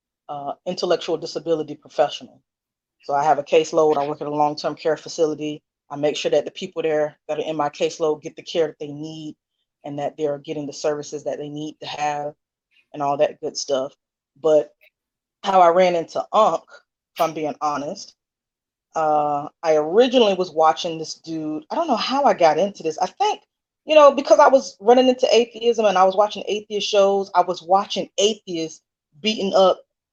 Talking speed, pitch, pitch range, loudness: 195 wpm, 160 Hz, 150-195 Hz, -20 LUFS